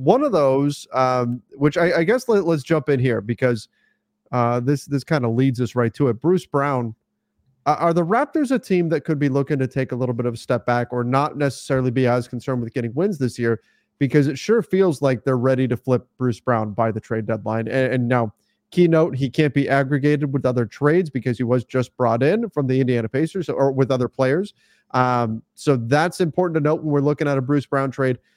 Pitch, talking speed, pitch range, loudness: 135 Hz, 235 wpm, 125-150 Hz, -20 LUFS